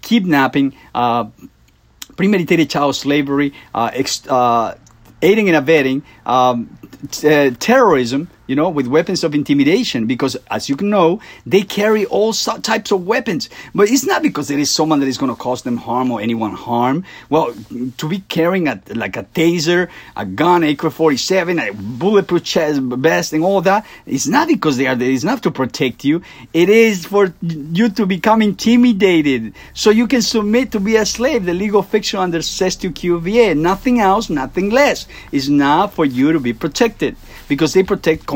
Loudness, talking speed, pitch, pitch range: -15 LUFS, 180 wpm, 170 Hz, 140-210 Hz